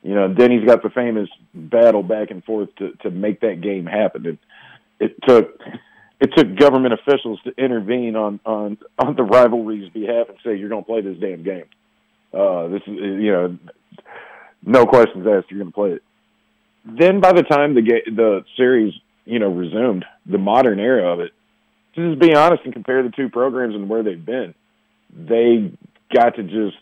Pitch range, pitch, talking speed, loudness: 105-130 Hz, 115 Hz, 195 wpm, -17 LUFS